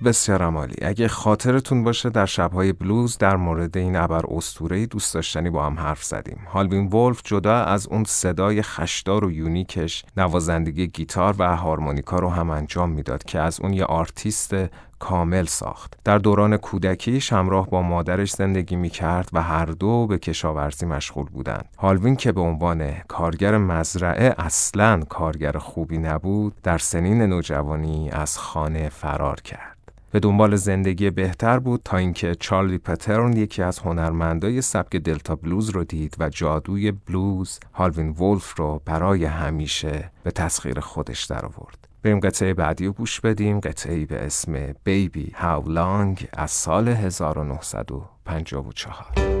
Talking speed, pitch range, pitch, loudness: 145 wpm, 80-100 Hz, 90 Hz, -22 LUFS